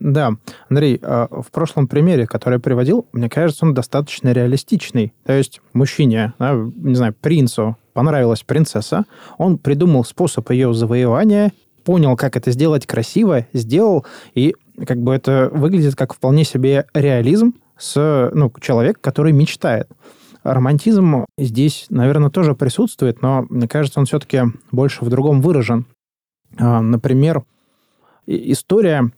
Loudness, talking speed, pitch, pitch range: -16 LUFS, 125 wpm, 135 Hz, 125-150 Hz